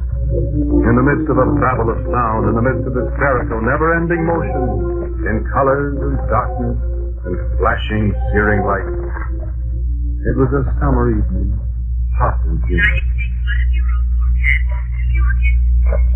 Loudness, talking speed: -17 LUFS, 120 wpm